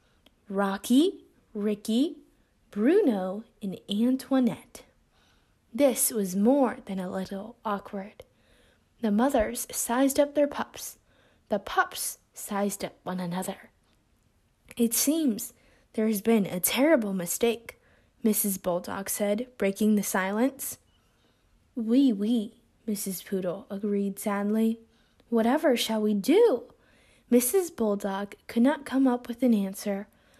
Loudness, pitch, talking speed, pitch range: -27 LUFS, 220 Hz, 115 wpm, 200-255 Hz